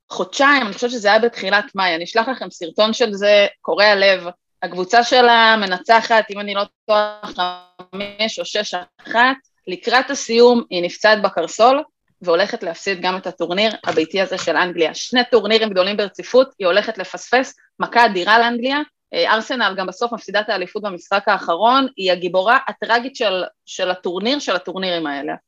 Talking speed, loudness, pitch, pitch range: 160 wpm, -17 LUFS, 205 Hz, 180-235 Hz